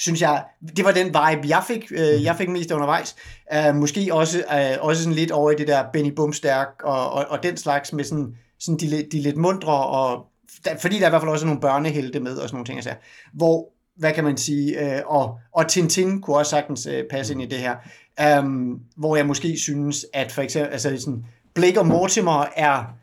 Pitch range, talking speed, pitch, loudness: 140-160 Hz, 210 wpm, 150 Hz, -21 LUFS